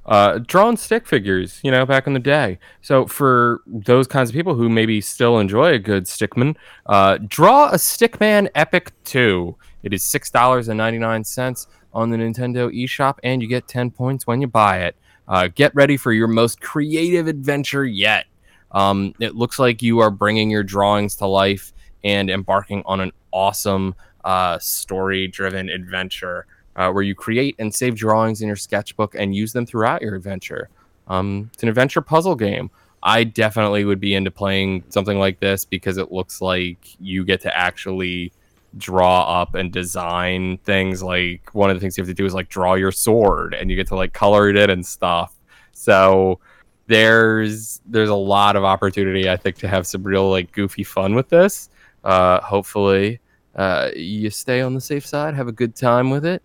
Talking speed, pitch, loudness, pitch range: 190 wpm, 100 Hz, -18 LUFS, 95-125 Hz